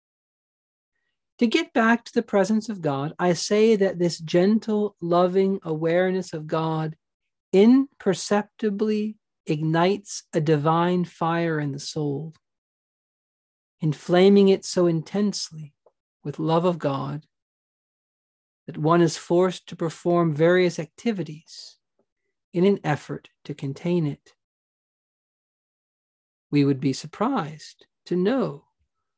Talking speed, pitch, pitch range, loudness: 110 wpm, 175 Hz, 155-195 Hz, -23 LUFS